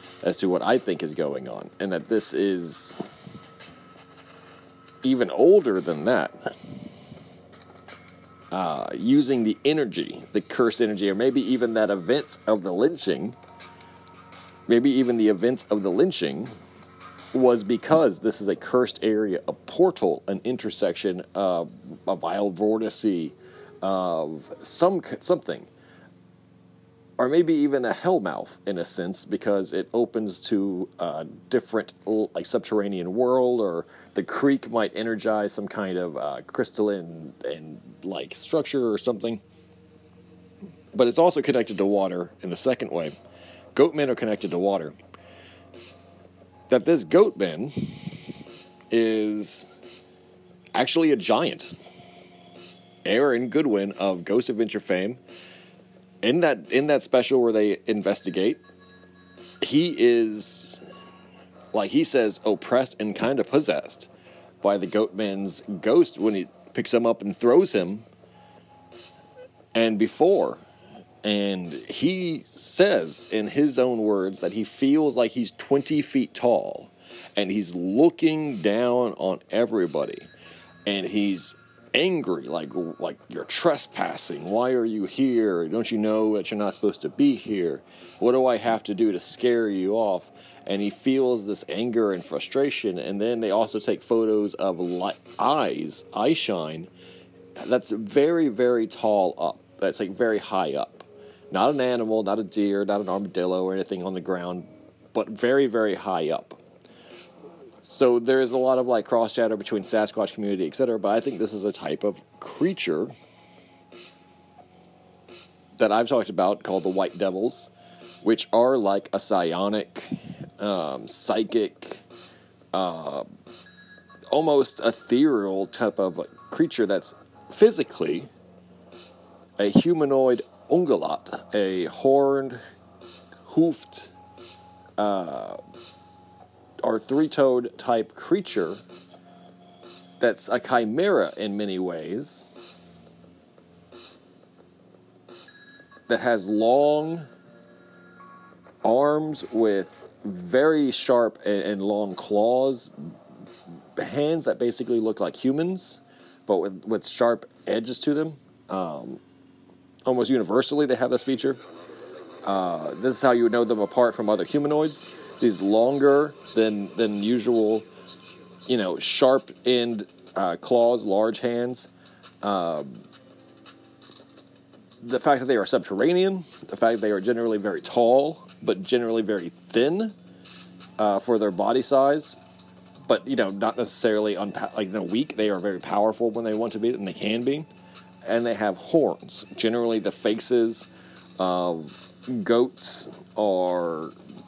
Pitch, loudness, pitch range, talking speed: 110 Hz, -24 LUFS, 95-125 Hz, 130 wpm